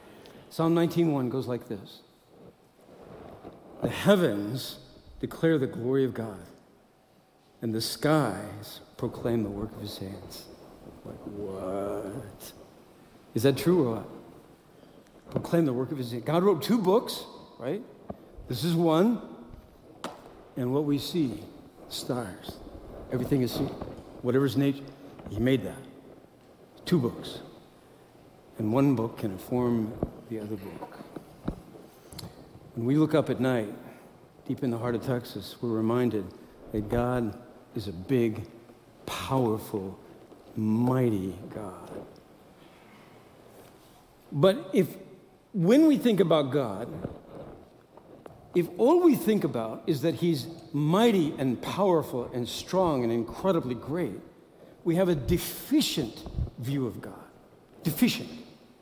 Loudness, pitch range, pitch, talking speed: -28 LUFS, 115-165 Hz, 130 Hz, 120 wpm